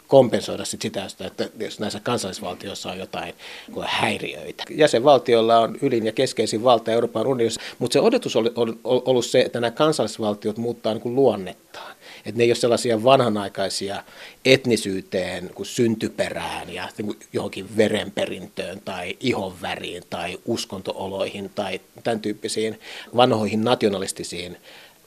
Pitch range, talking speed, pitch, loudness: 105-120 Hz, 115 wpm, 115 Hz, -22 LUFS